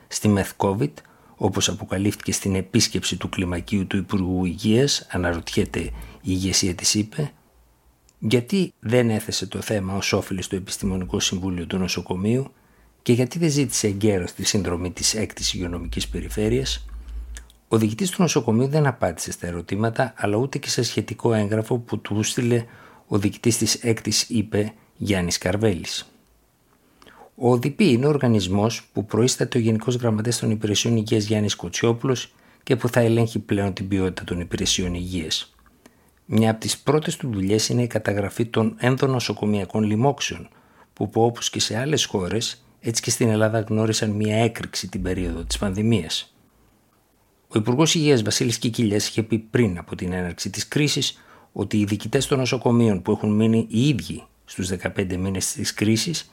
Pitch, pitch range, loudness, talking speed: 110 Hz, 95-120 Hz, -22 LUFS, 155 wpm